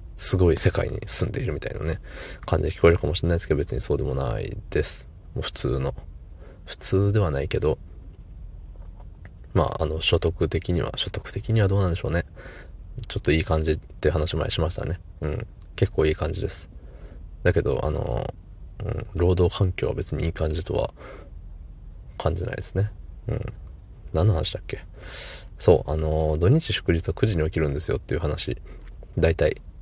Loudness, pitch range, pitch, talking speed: -25 LUFS, 80-95 Hz, 85 Hz, 340 characters per minute